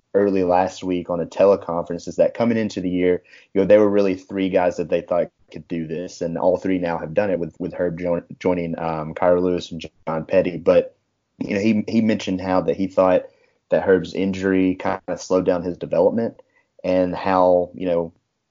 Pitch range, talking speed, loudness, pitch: 85-95 Hz, 215 wpm, -21 LUFS, 90 Hz